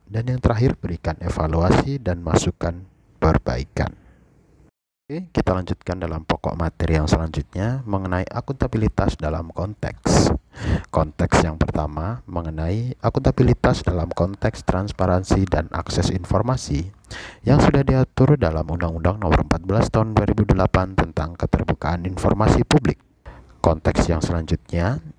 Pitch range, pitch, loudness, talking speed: 85-110 Hz, 90 Hz, -21 LUFS, 110 wpm